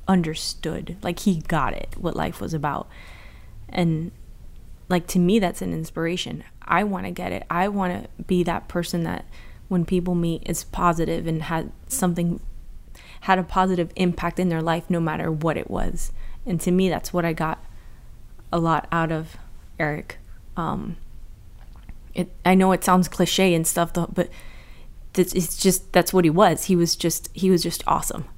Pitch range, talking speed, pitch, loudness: 165-185 Hz, 180 wpm, 175 Hz, -23 LUFS